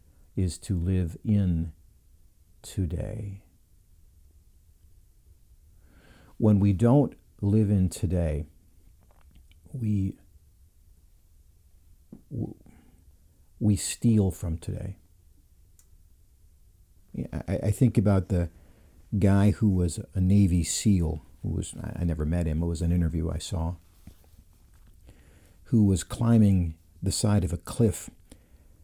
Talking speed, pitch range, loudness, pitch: 95 wpm, 80-100 Hz, -27 LUFS, 85 Hz